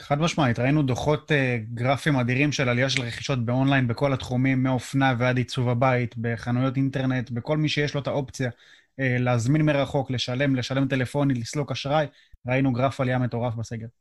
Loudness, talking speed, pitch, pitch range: -24 LUFS, 165 wpm, 130 Hz, 125-140 Hz